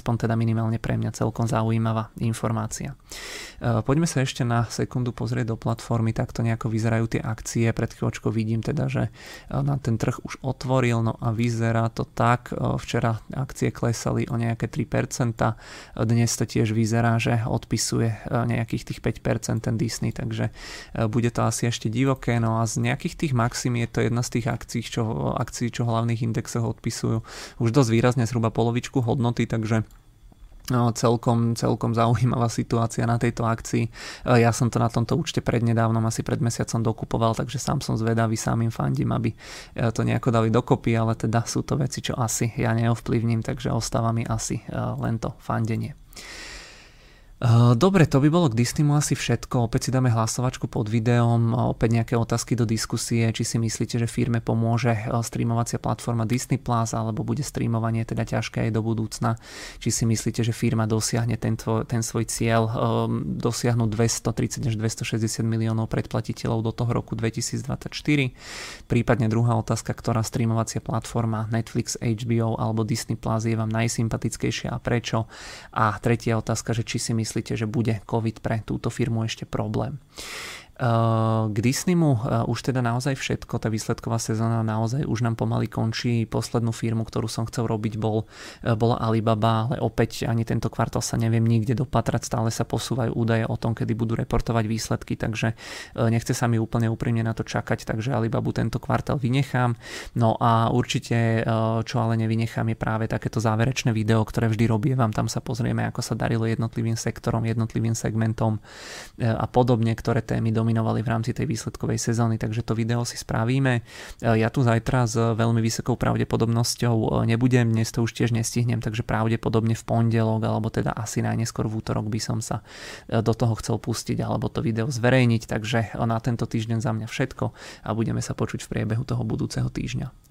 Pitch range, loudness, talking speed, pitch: 115-120 Hz, -24 LUFS, 170 wpm, 115 Hz